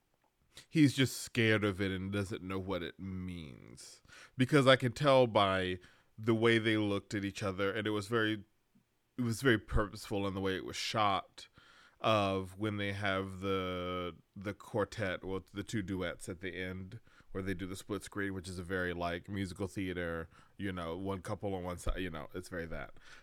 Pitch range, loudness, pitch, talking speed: 95-110 Hz, -35 LUFS, 100 Hz, 195 wpm